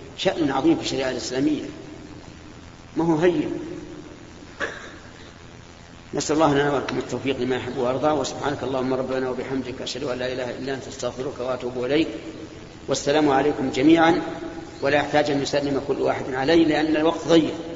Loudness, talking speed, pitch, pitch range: -23 LUFS, 140 wpm, 135 Hz, 125-160 Hz